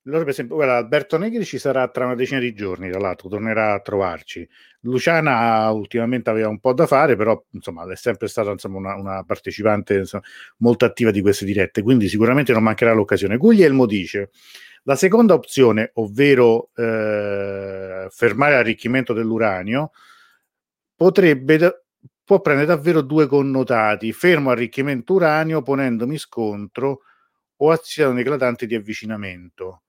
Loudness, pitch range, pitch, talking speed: -18 LUFS, 105-140 Hz, 120 Hz, 140 wpm